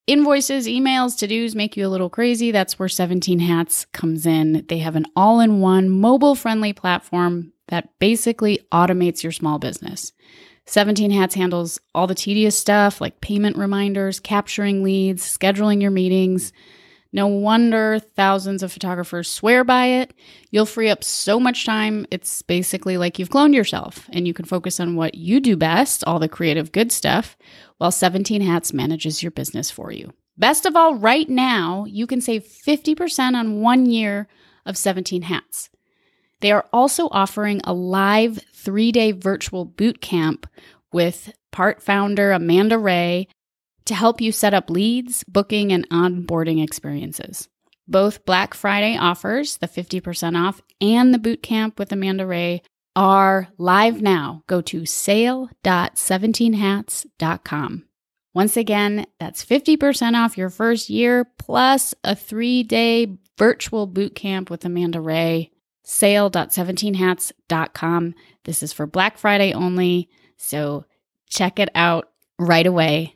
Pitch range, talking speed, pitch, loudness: 175-220 Hz, 145 wpm, 195 Hz, -19 LUFS